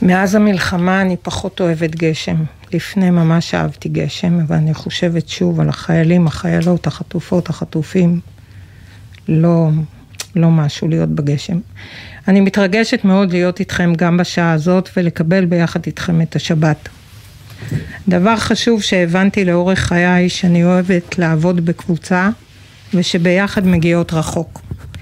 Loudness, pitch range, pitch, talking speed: -15 LUFS, 155-180 Hz, 170 Hz, 120 wpm